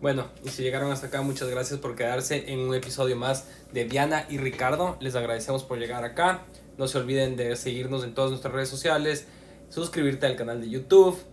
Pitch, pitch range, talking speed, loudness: 135 Hz, 125-140 Hz, 200 wpm, -27 LUFS